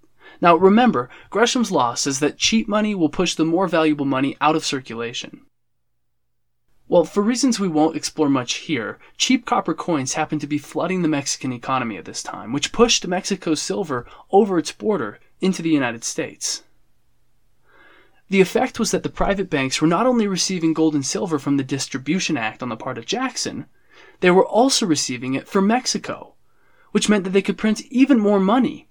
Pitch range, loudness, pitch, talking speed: 145-205 Hz, -20 LUFS, 170 Hz, 185 wpm